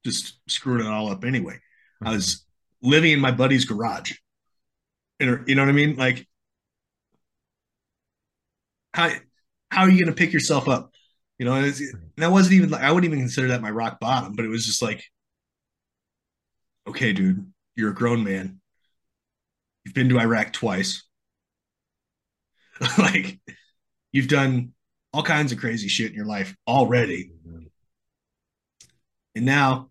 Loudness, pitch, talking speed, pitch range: -22 LUFS, 125 Hz, 155 wpm, 110-145 Hz